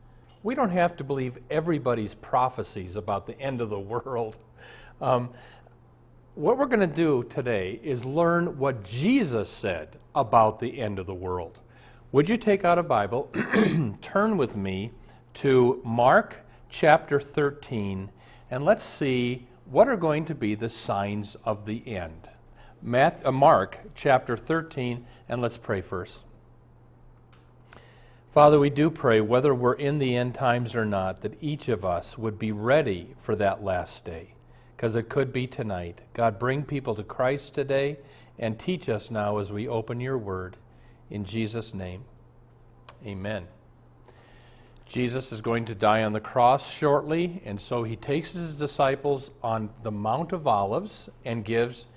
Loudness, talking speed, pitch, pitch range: -26 LUFS, 155 wpm, 120 Hz, 110-140 Hz